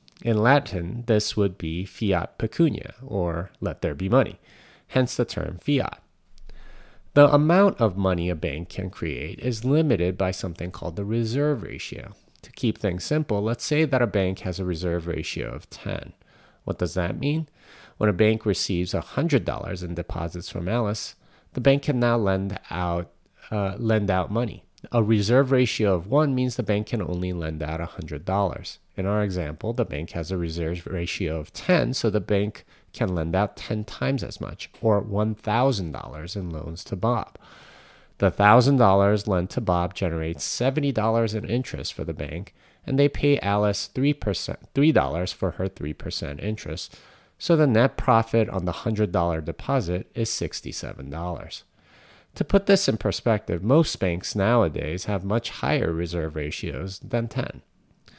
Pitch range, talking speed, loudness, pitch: 85-120 Hz, 160 wpm, -25 LUFS, 100 Hz